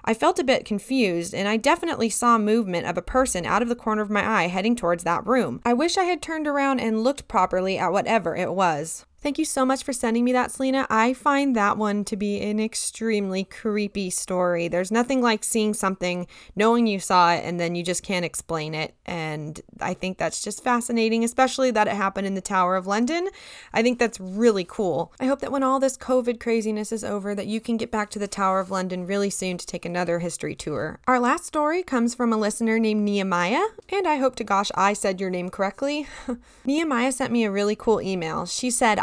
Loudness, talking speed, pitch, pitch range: -23 LUFS, 225 wpm, 215 Hz, 190-250 Hz